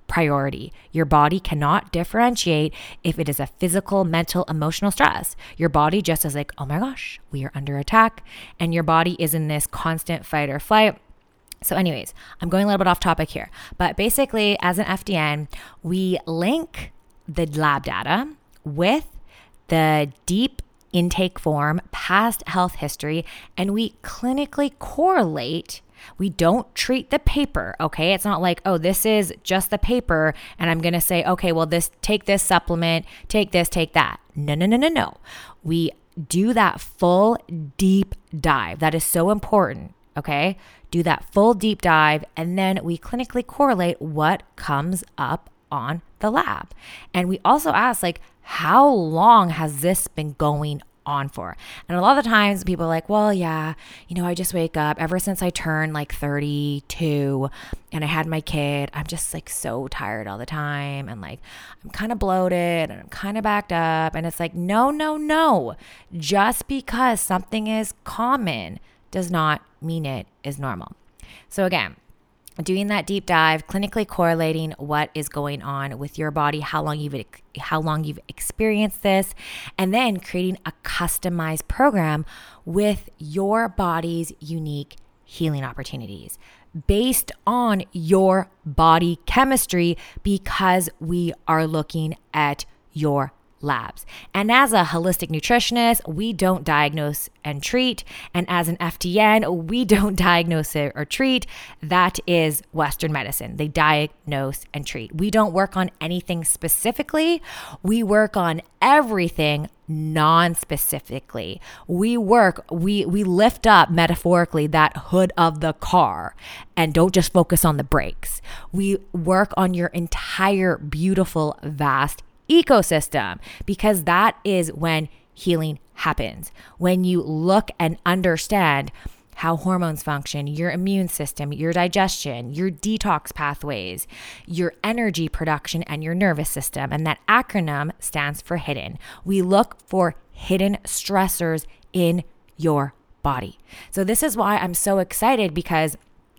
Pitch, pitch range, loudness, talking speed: 170 Hz, 155-195 Hz, -21 LUFS, 150 wpm